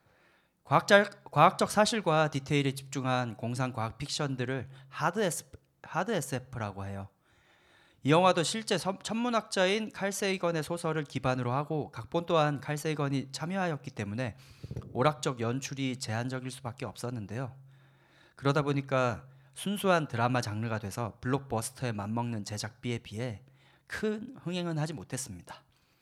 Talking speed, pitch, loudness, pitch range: 315 characters per minute, 135 Hz, -31 LUFS, 120-165 Hz